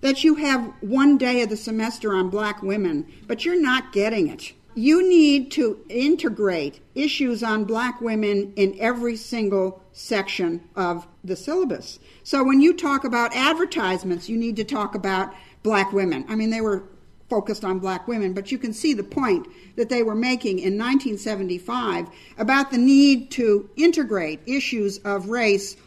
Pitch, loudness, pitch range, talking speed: 225 Hz, -22 LUFS, 200-270 Hz, 165 wpm